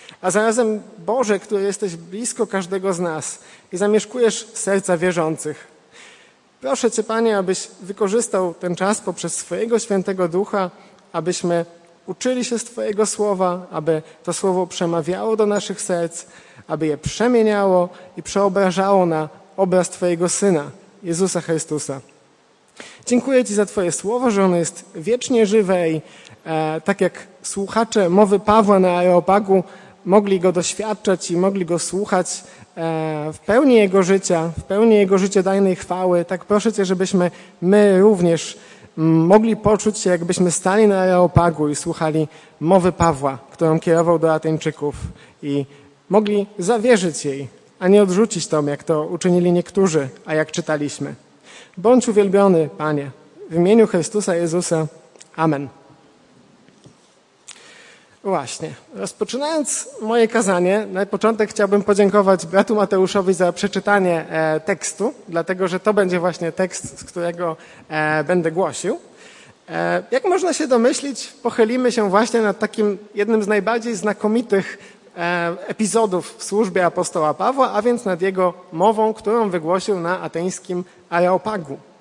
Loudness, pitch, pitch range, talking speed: -19 LUFS, 190 Hz, 170-210 Hz, 130 wpm